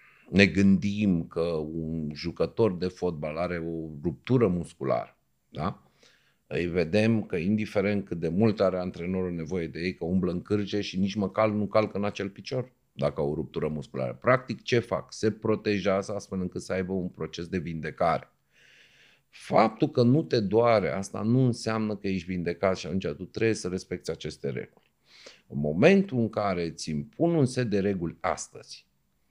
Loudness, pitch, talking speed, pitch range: -28 LUFS, 95 Hz, 170 wpm, 85-110 Hz